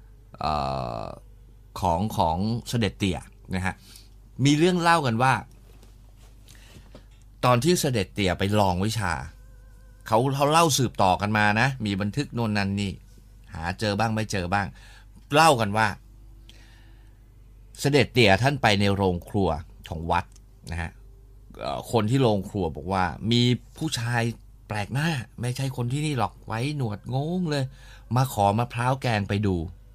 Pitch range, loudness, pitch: 100-120 Hz, -25 LUFS, 110 Hz